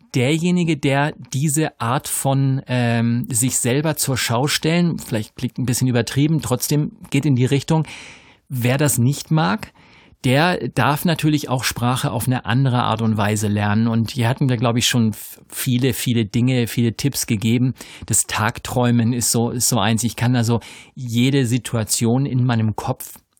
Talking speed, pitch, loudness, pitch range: 165 wpm, 125 Hz, -19 LUFS, 115-140 Hz